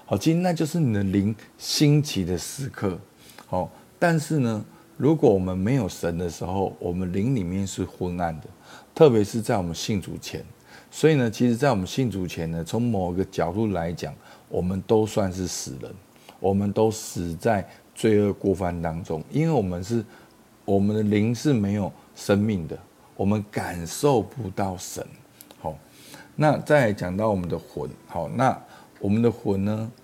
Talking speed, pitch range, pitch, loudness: 245 characters per minute, 90-120 Hz, 105 Hz, -25 LUFS